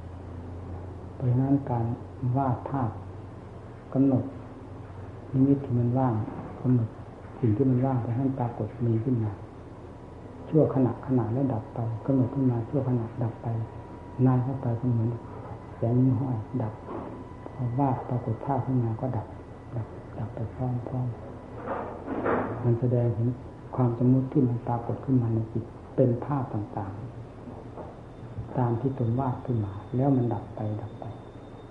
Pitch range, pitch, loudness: 110-130 Hz, 120 Hz, -28 LUFS